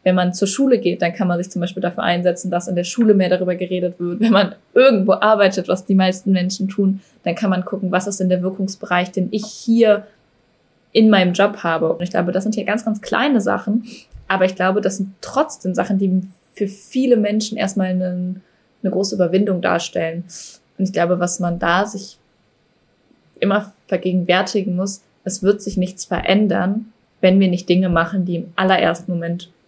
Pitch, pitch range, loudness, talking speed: 190 Hz, 180-205 Hz, -18 LUFS, 195 wpm